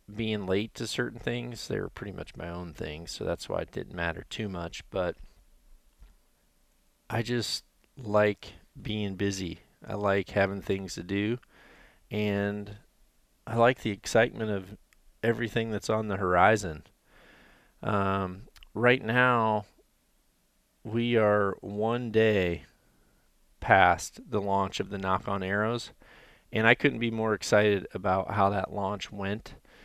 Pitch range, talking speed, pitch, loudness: 95-110 Hz, 140 wpm, 105 Hz, -29 LUFS